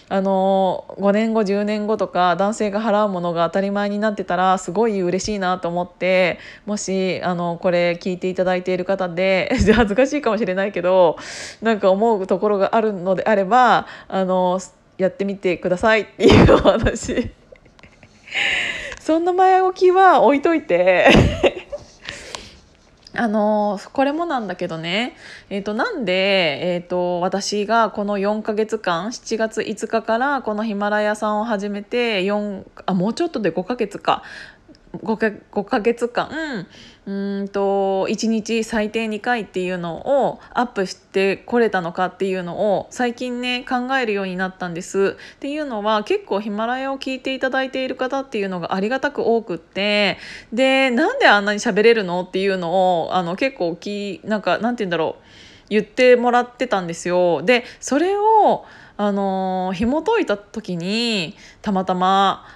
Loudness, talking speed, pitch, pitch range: -19 LUFS, 295 characters per minute, 205 Hz, 185-230 Hz